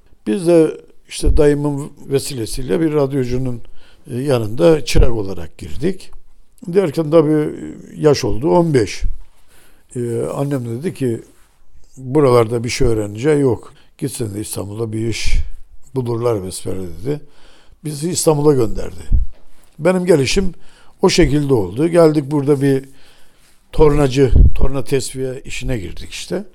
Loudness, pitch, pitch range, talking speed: -17 LUFS, 130 Hz, 110-150 Hz, 115 wpm